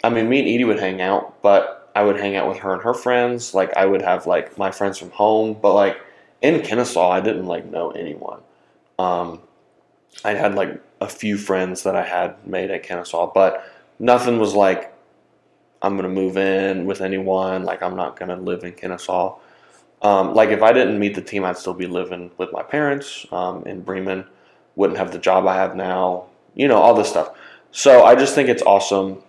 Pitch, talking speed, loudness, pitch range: 95 Hz, 210 wpm, -18 LUFS, 95-105 Hz